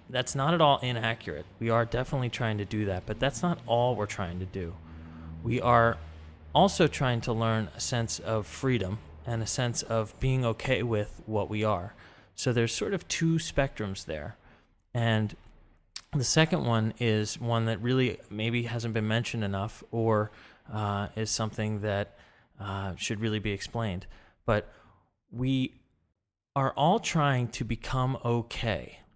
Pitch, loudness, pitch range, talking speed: 115 Hz, -29 LUFS, 105-125 Hz, 160 wpm